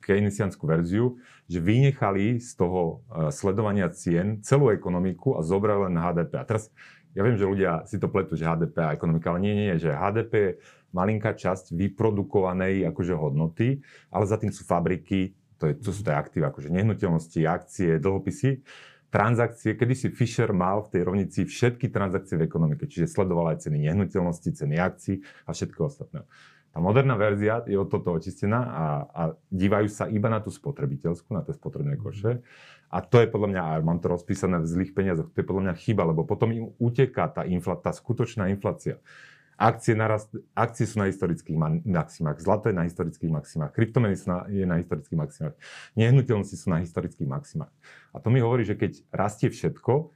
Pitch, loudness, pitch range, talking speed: 100 Hz, -26 LUFS, 90-115 Hz, 185 wpm